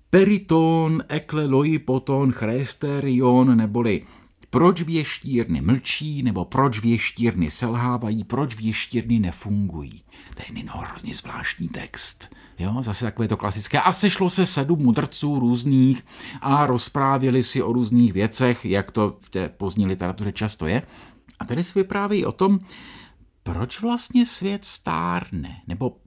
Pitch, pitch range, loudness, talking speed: 130 Hz, 110-155 Hz, -22 LUFS, 130 wpm